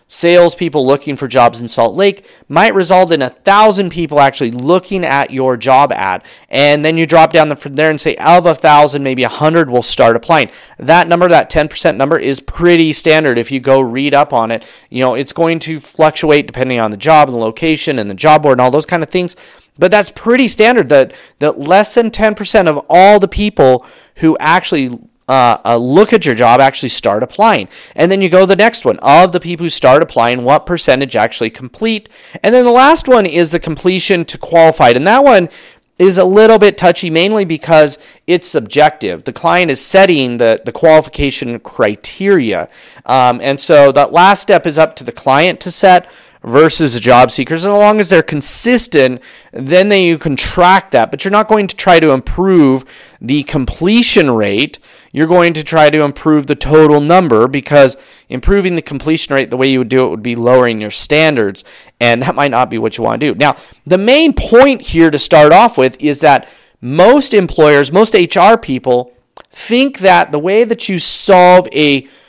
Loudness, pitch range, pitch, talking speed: -10 LUFS, 135-185 Hz, 155 Hz, 205 wpm